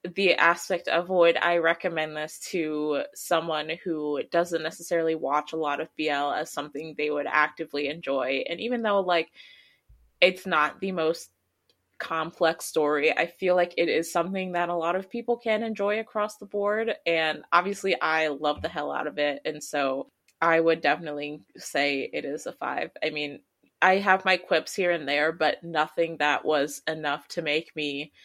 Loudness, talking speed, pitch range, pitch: -26 LUFS, 180 wpm, 150-180 Hz, 165 Hz